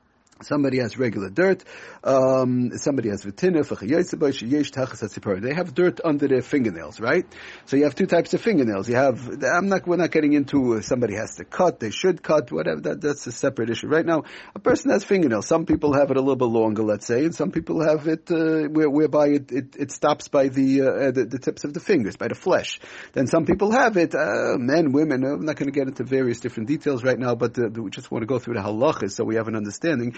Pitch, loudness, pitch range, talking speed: 140 Hz, -22 LUFS, 125-160 Hz, 230 wpm